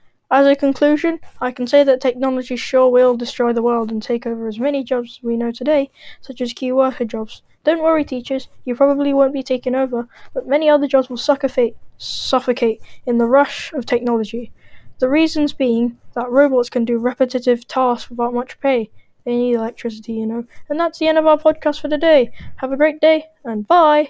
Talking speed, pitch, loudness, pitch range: 200 wpm, 255 Hz, -17 LUFS, 240-285 Hz